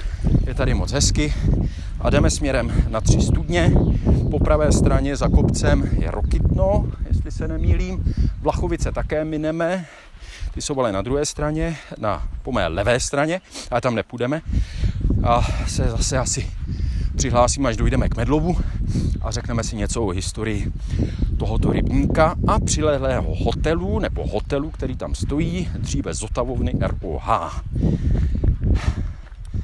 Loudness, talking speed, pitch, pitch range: -21 LUFS, 130 wpm, 95 Hz, 85-115 Hz